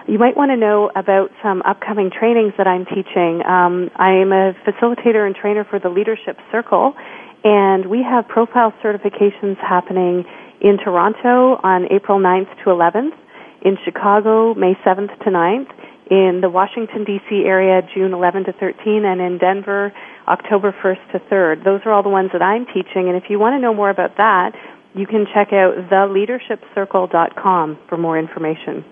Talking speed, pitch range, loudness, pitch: 170 wpm, 185-215 Hz, -15 LUFS, 195 Hz